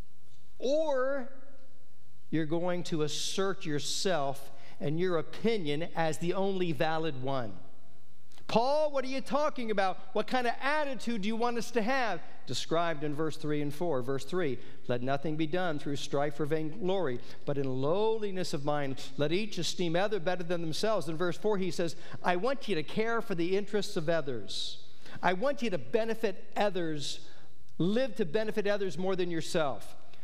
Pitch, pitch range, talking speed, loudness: 180 Hz, 155-215 Hz, 170 wpm, -33 LUFS